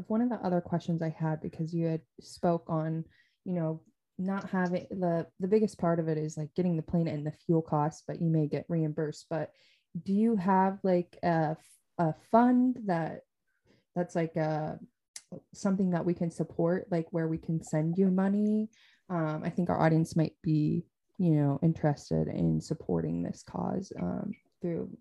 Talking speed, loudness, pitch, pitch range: 180 wpm, -31 LUFS, 165 Hz, 155-180 Hz